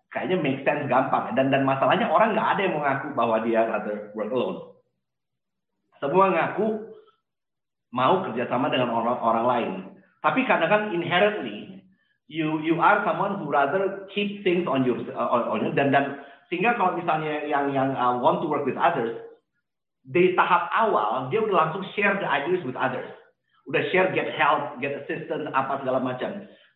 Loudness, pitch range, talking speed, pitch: -24 LUFS, 135-195 Hz, 170 wpm, 160 Hz